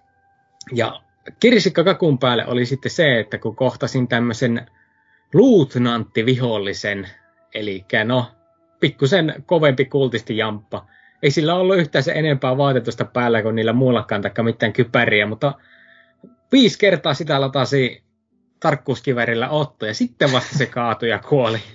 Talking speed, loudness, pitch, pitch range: 125 wpm, -18 LUFS, 130 Hz, 115-160 Hz